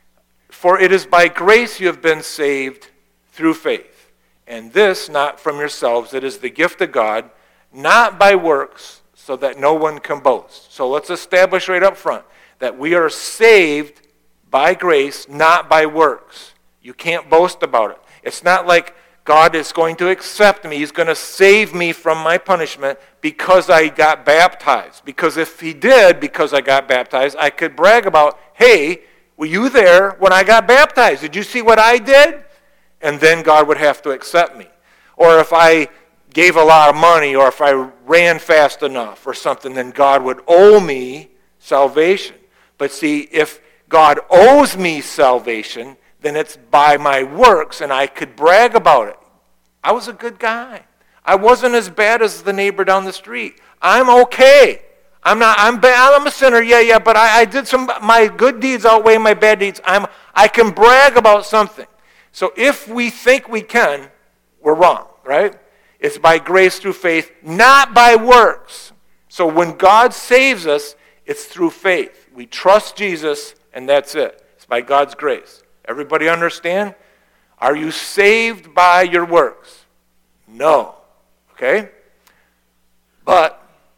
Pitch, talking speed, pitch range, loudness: 180 Hz, 170 wpm, 150-230 Hz, -12 LUFS